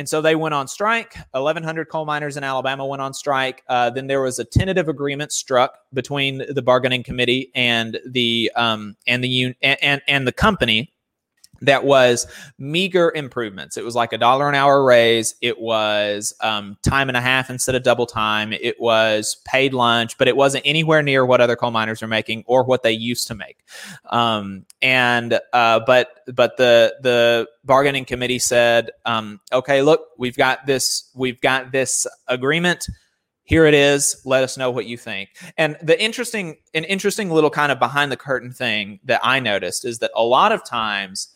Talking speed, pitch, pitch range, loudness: 190 wpm, 130 Hz, 120-140 Hz, -18 LUFS